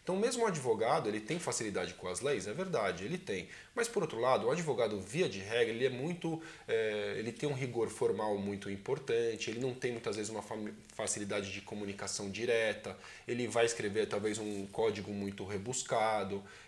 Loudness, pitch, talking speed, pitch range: -36 LUFS, 110 Hz, 185 wpm, 100-125 Hz